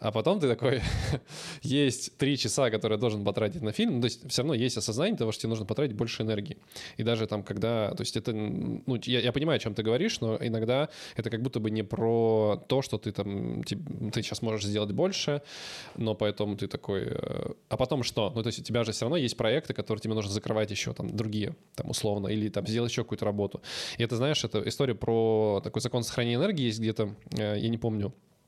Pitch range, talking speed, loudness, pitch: 105-125 Hz, 225 wpm, -30 LUFS, 115 Hz